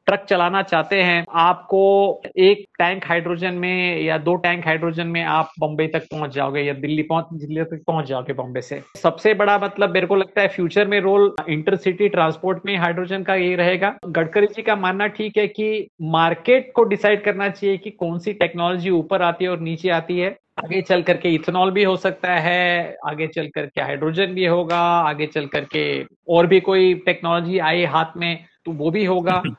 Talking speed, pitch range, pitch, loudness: 195 wpm, 165-195 Hz, 175 Hz, -19 LUFS